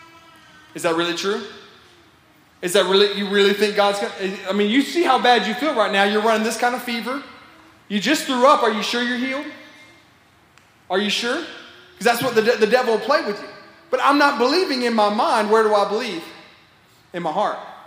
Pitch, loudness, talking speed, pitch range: 230 Hz, -19 LUFS, 215 wpm, 205-260 Hz